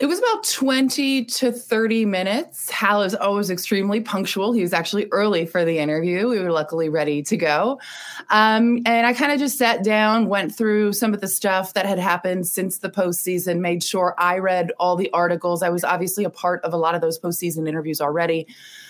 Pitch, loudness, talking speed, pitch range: 190 Hz, -20 LUFS, 205 wpm, 175-225 Hz